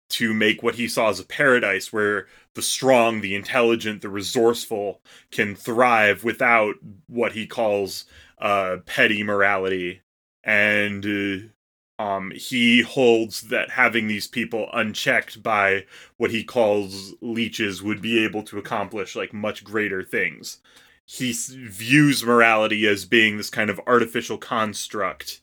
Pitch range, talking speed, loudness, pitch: 100-115 Hz, 140 wpm, -21 LUFS, 105 Hz